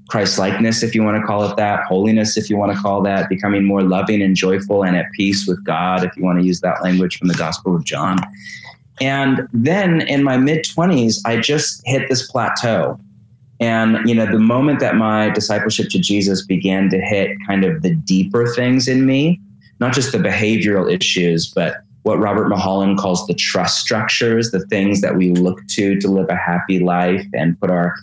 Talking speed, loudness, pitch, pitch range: 205 wpm, -16 LUFS, 100 Hz, 95-115 Hz